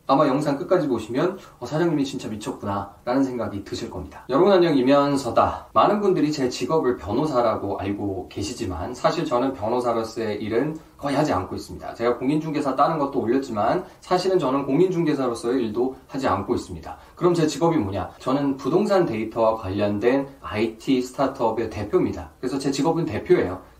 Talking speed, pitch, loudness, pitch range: 410 characters per minute, 125 Hz, -23 LUFS, 110-150 Hz